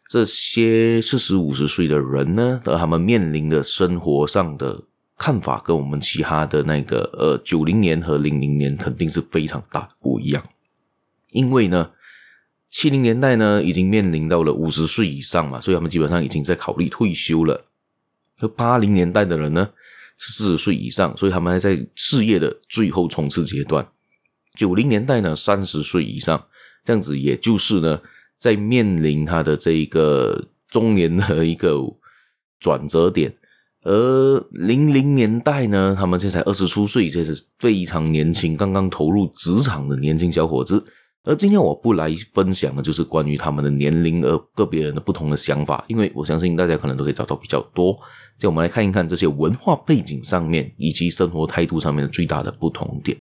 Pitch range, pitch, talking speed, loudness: 75-100 Hz, 85 Hz, 280 characters per minute, -19 LUFS